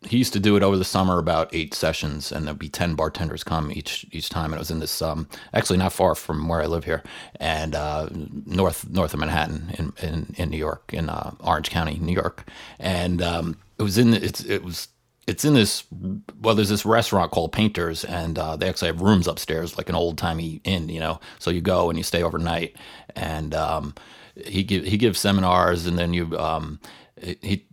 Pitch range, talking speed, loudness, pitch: 80-95 Hz, 220 wpm, -24 LUFS, 85 Hz